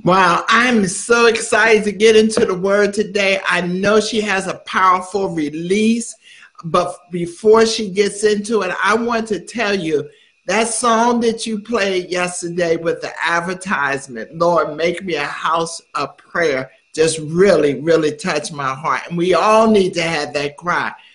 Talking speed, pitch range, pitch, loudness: 165 wpm, 165-220 Hz, 190 Hz, -16 LUFS